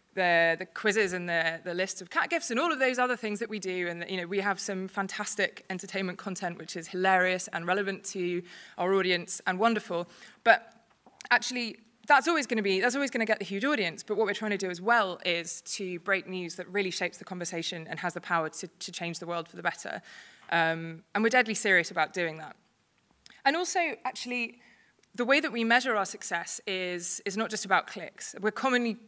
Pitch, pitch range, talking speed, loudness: 195 Hz, 175-225 Hz, 225 wpm, -29 LUFS